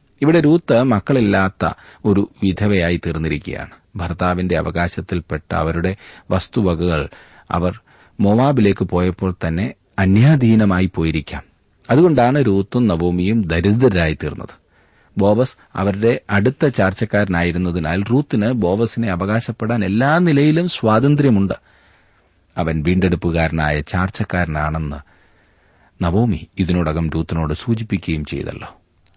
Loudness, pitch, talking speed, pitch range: -17 LUFS, 95 Hz, 80 wpm, 85-115 Hz